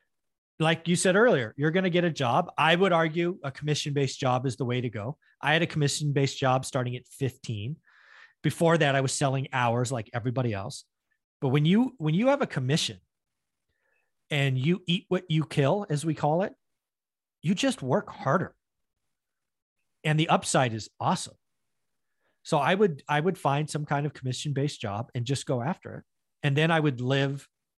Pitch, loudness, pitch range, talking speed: 145 Hz, -27 LUFS, 135-170 Hz, 190 wpm